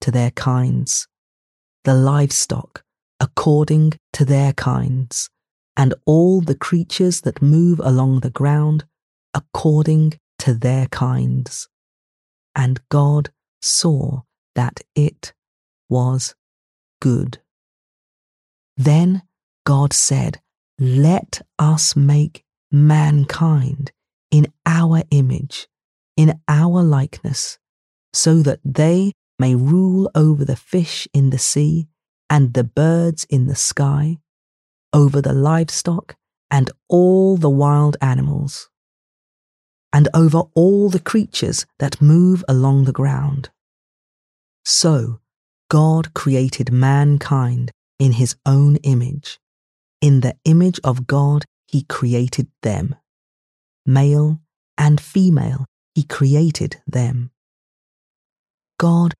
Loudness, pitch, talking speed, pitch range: -16 LUFS, 145 Hz, 100 wpm, 130-155 Hz